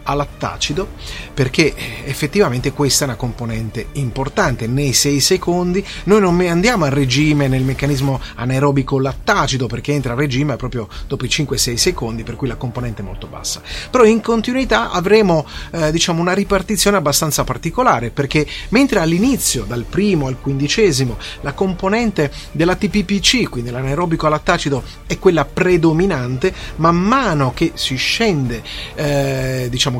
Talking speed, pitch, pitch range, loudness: 140 wpm, 145 Hz, 130-180 Hz, -16 LUFS